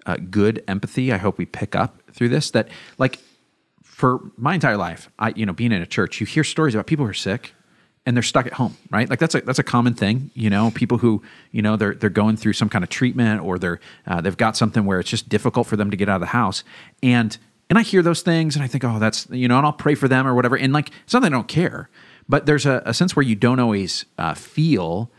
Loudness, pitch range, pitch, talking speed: -20 LUFS, 105-140 Hz, 120 Hz, 275 wpm